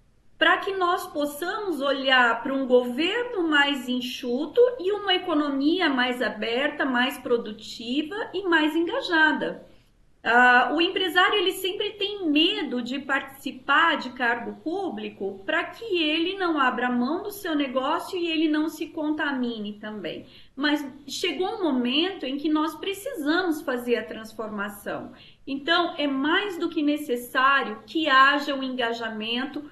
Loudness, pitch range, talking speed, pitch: -24 LUFS, 250-340 Hz, 140 wpm, 295 Hz